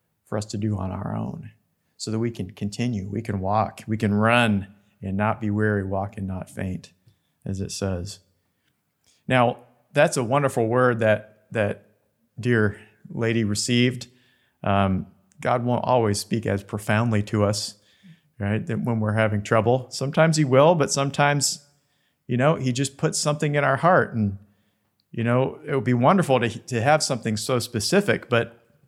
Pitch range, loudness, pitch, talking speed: 105-130 Hz, -23 LUFS, 115 Hz, 170 wpm